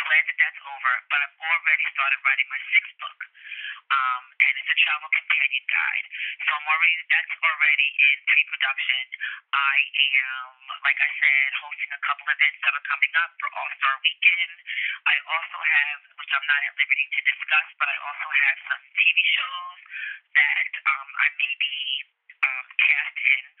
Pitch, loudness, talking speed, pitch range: 155 Hz, -21 LUFS, 180 wpm, 140-175 Hz